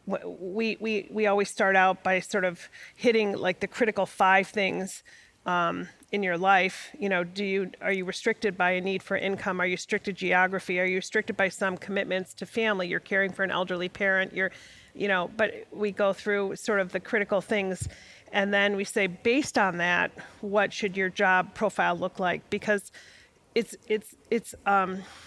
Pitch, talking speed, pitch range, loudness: 195 Hz, 190 wpm, 185-205 Hz, -27 LUFS